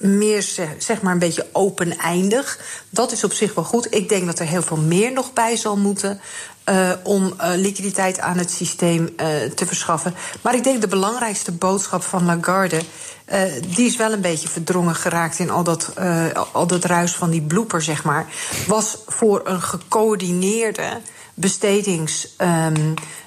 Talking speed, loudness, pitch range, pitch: 170 wpm, -19 LUFS, 170-205 Hz, 185 Hz